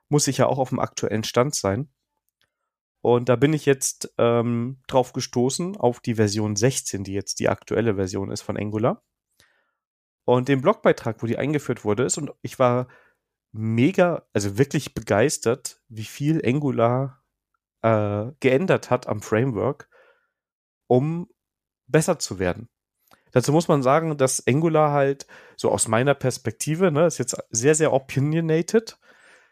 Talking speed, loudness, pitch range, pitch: 150 wpm, -22 LUFS, 115-150 Hz, 130 Hz